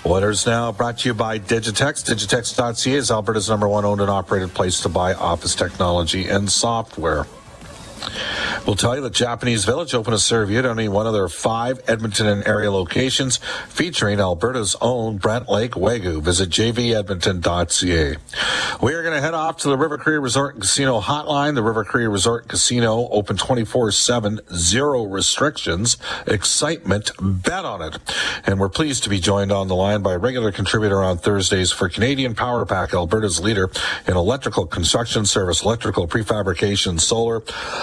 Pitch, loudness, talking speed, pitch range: 110 Hz, -19 LUFS, 170 wpm, 100-120 Hz